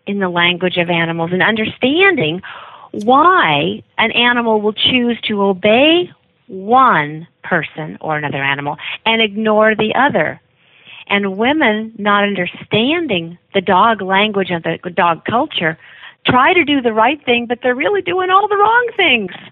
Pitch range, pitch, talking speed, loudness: 180-245 Hz, 215 Hz, 150 wpm, -14 LUFS